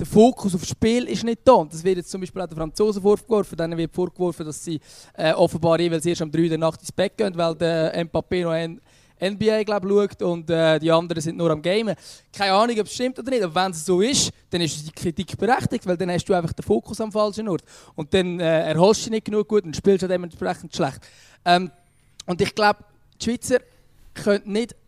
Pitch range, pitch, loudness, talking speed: 165-205 Hz, 180 Hz, -22 LUFS, 235 wpm